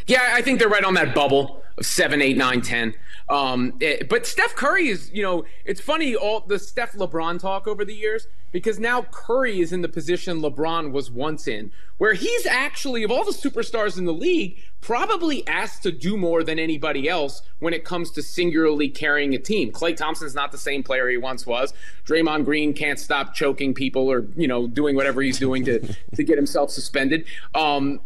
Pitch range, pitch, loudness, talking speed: 140-215 Hz, 165 Hz, -22 LUFS, 205 wpm